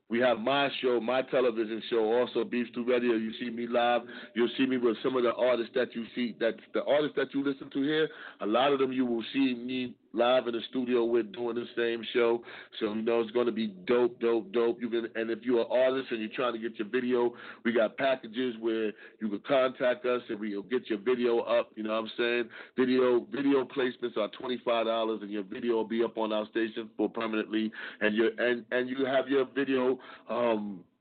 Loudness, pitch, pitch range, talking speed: -30 LUFS, 120 Hz, 115-125 Hz, 235 wpm